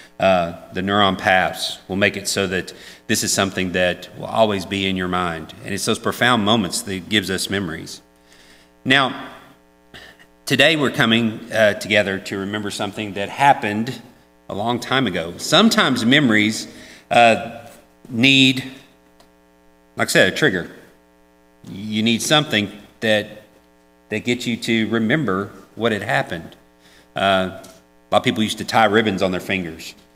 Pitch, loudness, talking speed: 100 Hz, -18 LUFS, 150 wpm